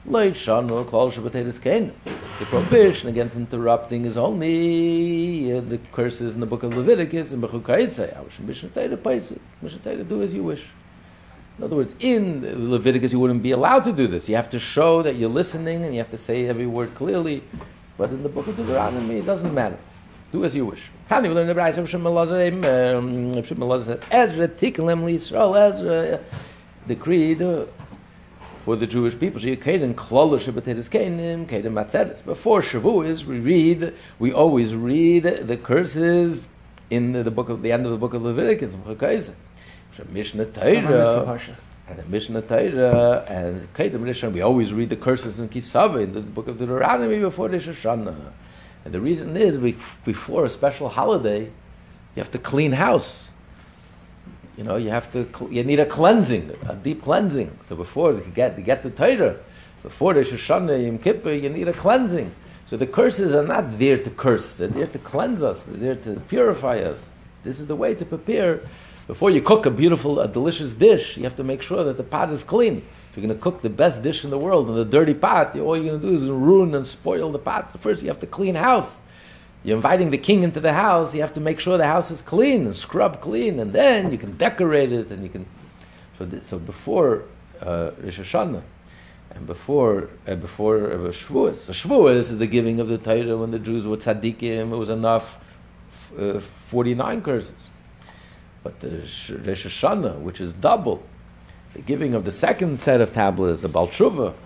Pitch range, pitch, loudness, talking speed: 115-165 Hz, 125 Hz, -21 LUFS, 195 wpm